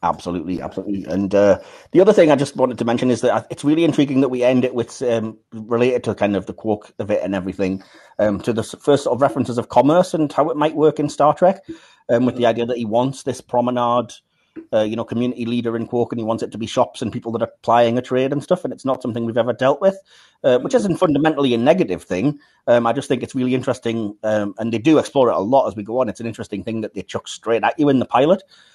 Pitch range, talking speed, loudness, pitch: 115-140 Hz, 270 wpm, -19 LUFS, 120 Hz